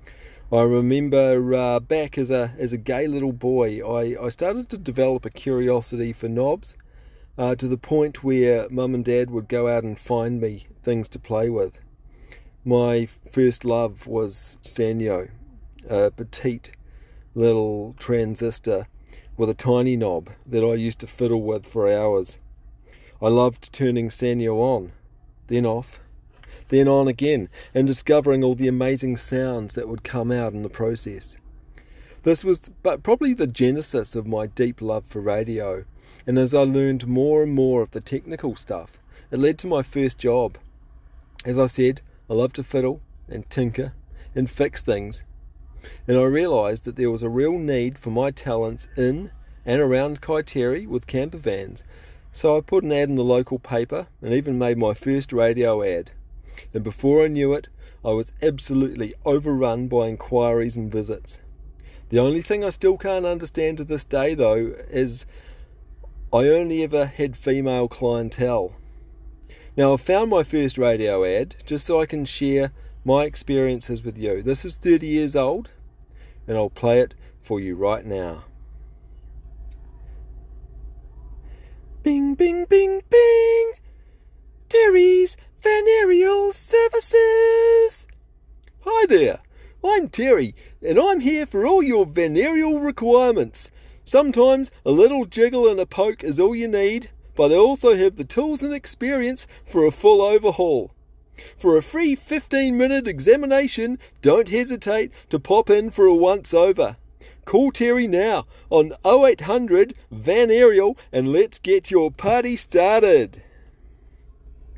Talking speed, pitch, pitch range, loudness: 150 wpm, 130 Hz, 115-180 Hz, -20 LUFS